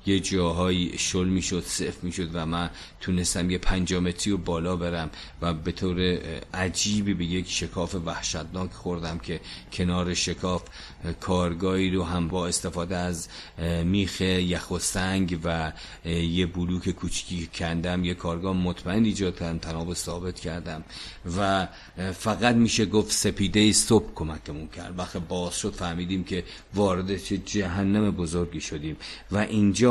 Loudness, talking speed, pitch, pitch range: -27 LUFS, 135 wpm, 90 Hz, 85-95 Hz